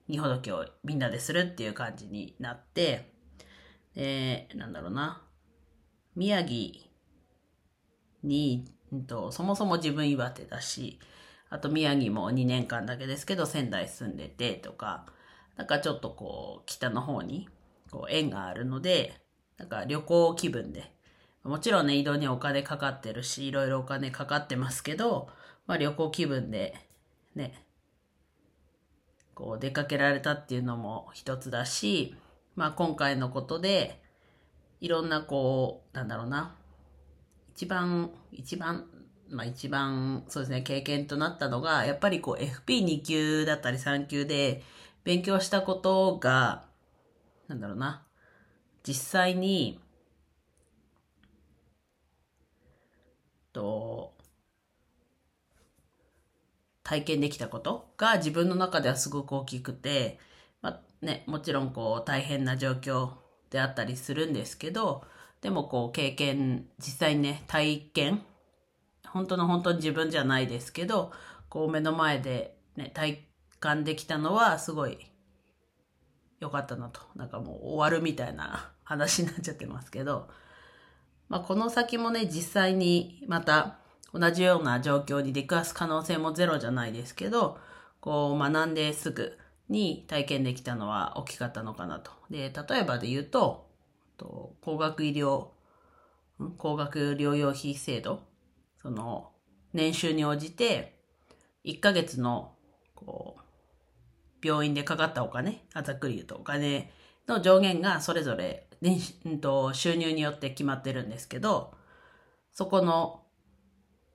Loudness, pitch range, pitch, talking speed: -30 LUFS, 120-160 Hz, 140 Hz, 245 characters per minute